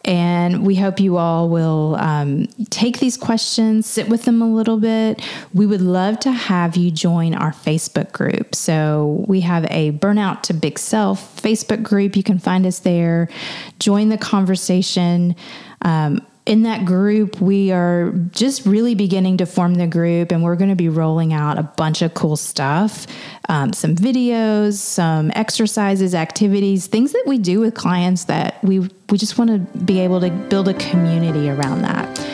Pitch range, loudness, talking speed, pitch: 170-215 Hz, -17 LUFS, 175 wpm, 190 Hz